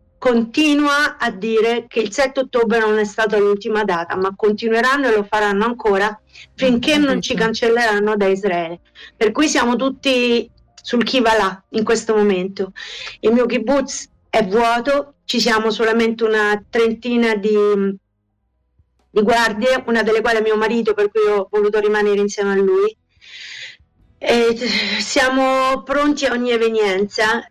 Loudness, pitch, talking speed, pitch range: -17 LUFS, 225 Hz, 145 wpm, 210-245 Hz